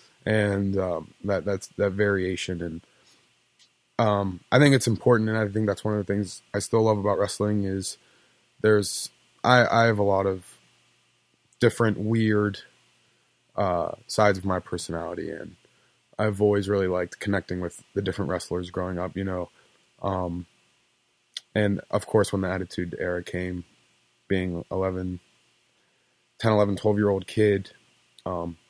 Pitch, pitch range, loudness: 95 Hz, 90-105 Hz, -25 LUFS